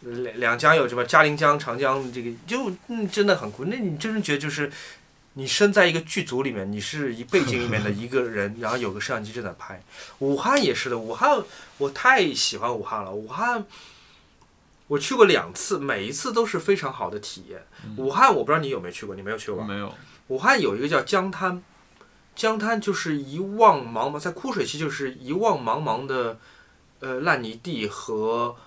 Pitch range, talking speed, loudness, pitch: 120-195 Hz, 290 characters per minute, -23 LUFS, 140 Hz